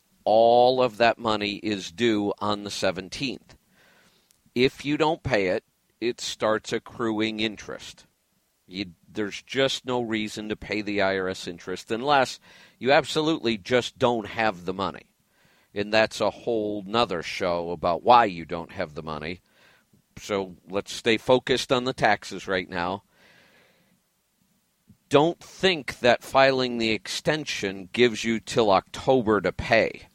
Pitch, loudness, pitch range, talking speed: 110 Hz, -25 LUFS, 95-125 Hz, 140 wpm